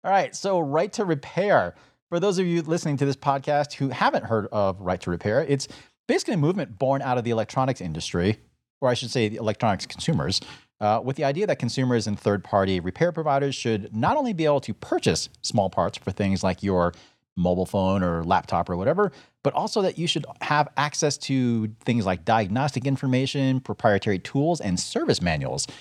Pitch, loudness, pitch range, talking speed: 125 Hz, -24 LUFS, 100-145 Hz, 200 wpm